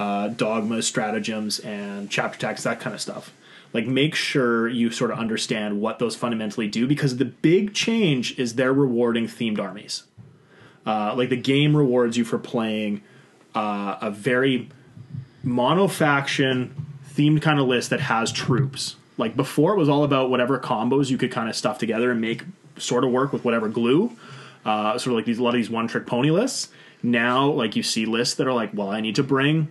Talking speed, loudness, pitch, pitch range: 195 wpm, -23 LUFS, 125 Hz, 115-140 Hz